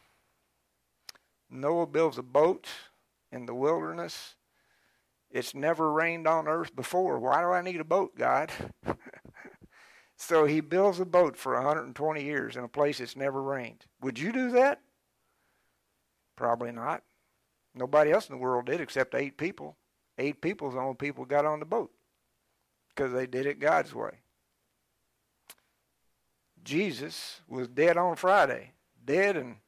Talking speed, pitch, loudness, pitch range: 140 wpm, 145 Hz, -29 LUFS, 125-165 Hz